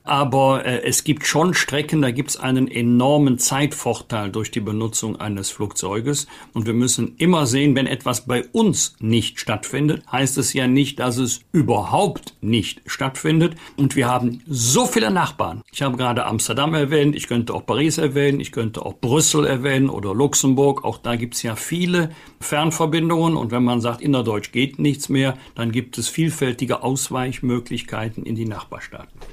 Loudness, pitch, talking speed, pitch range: -20 LUFS, 130 Hz, 175 wpm, 120-145 Hz